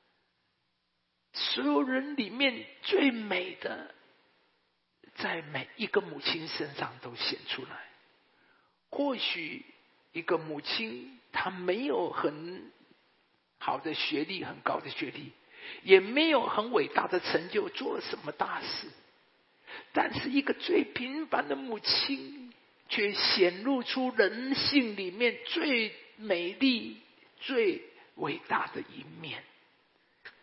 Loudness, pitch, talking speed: -31 LUFS, 260 Hz, 160 characters per minute